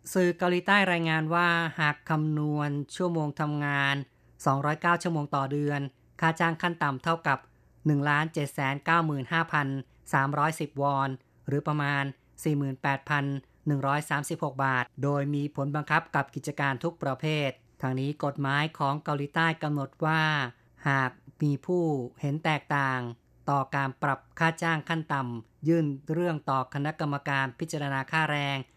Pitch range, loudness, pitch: 140-160 Hz, -28 LUFS, 145 Hz